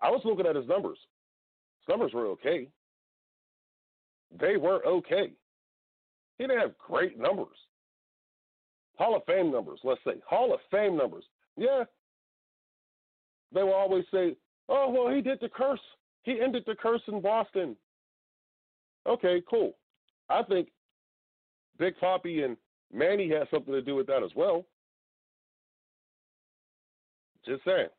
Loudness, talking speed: -29 LUFS, 135 wpm